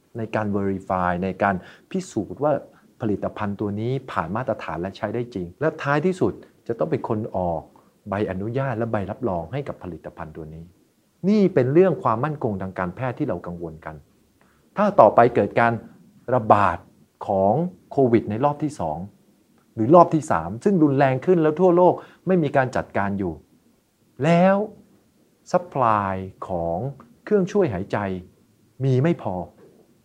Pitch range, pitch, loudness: 95-155 Hz, 115 Hz, -22 LUFS